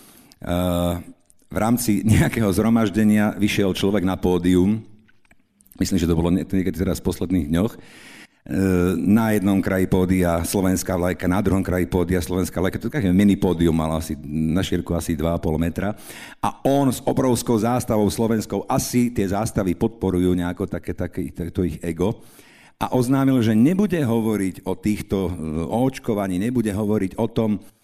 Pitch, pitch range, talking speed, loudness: 95 Hz, 90-110 Hz, 155 wpm, -21 LUFS